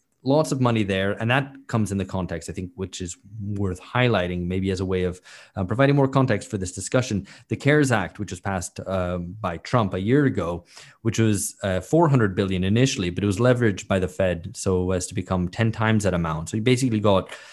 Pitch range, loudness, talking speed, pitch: 95-120 Hz, -23 LUFS, 225 wpm, 100 Hz